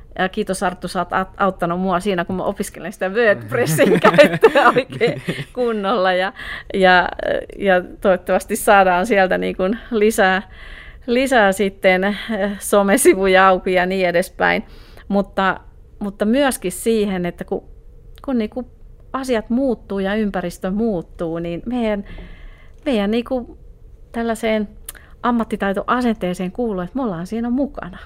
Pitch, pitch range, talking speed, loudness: 200 Hz, 185-230 Hz, 125 wpm, -18 LUFS